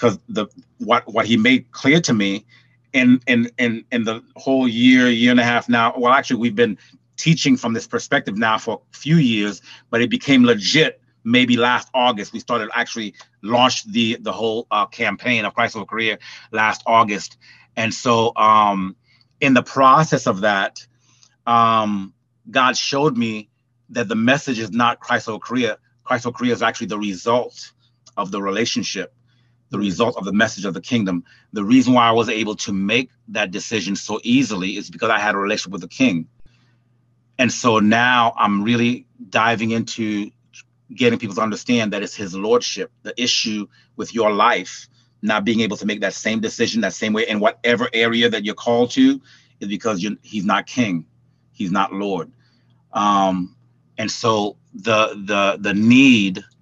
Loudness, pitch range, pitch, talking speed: -18 LUFS, 110-130 Hz, 120 Hz, 180 wpm